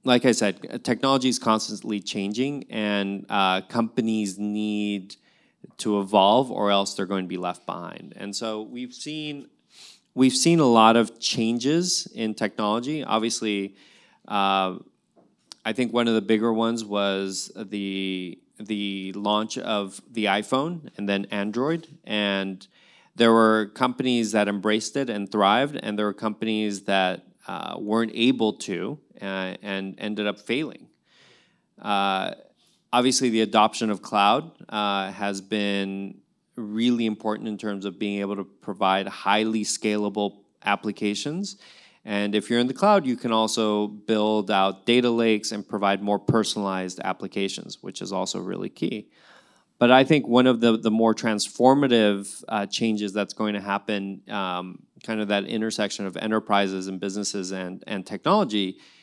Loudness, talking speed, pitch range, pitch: -24 LUFS, 145 wpm, 100-115 Hz, 105 Hz